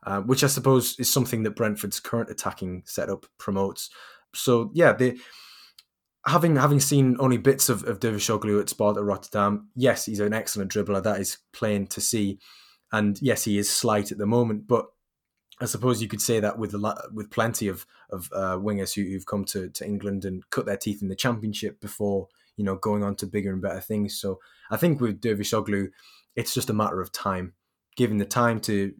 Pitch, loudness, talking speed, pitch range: 105 Hz, -25 LUFS, 210 wpm, 100-120 Hz